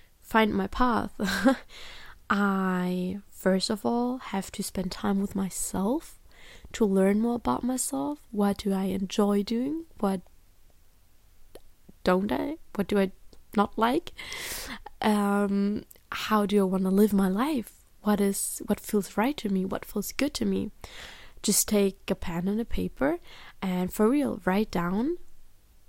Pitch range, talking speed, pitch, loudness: 190-235 Hz, 150 wpm, 205 Hz, -28 LUFS